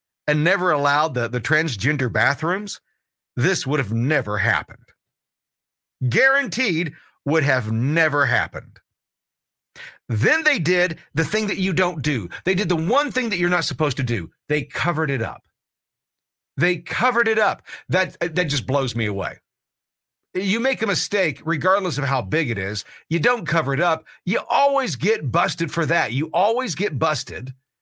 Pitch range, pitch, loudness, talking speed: 135-185 Hz, 160 Hz, -21 LUFS, 165 wpm